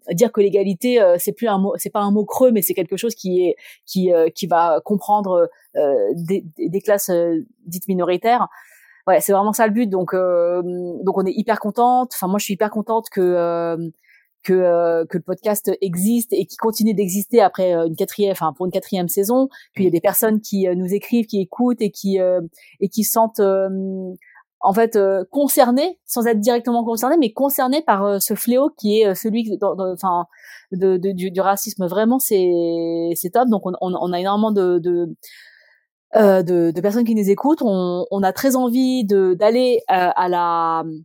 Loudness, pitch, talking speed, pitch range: -18 LUFS, 200 Hz, 210 wpm, 180-225 Hz